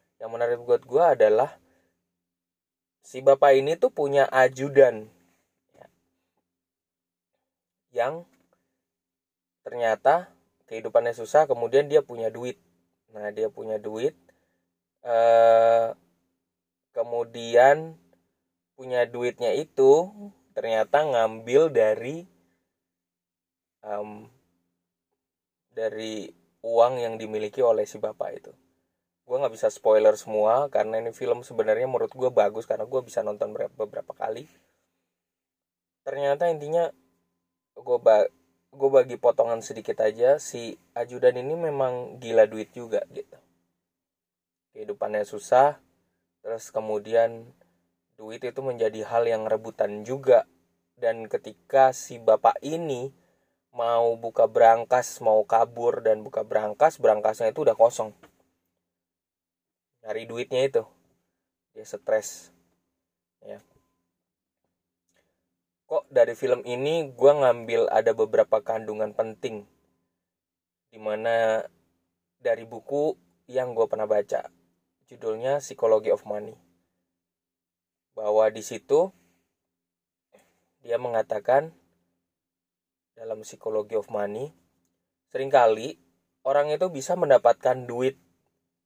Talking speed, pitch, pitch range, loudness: 95 wpm, 110 Hz, 85-135 Hz, -24 LUFS